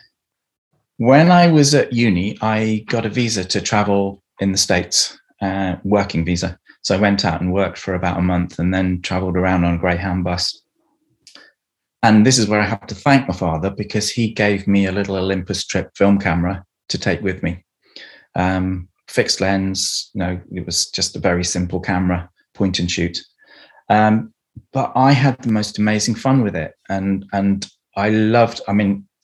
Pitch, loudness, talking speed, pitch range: 100 Hz, -18 LUFS, 185 wpm, 90-105 Hz